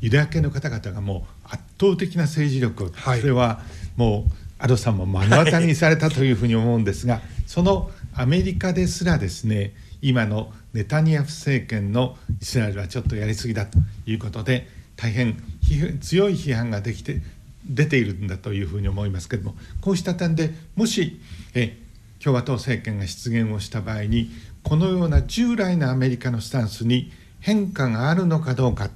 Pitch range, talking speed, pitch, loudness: 105-150 Hz, 360 characters per minute, 120 Hz, -22 LUFS